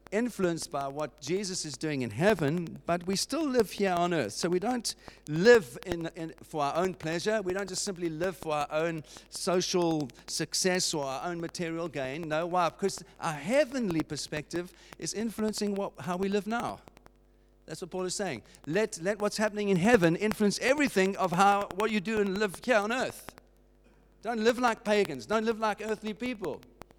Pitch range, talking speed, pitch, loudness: 165-210 Hz, 190 wpm, 185 Hz, -30 LUFS